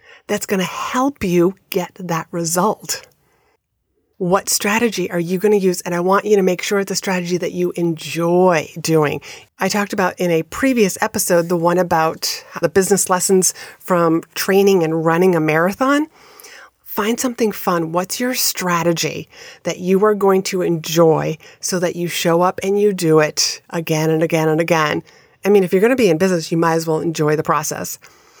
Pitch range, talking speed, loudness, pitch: 170-200 Hz, 185 wpm, -17 LUFS, 180 Hz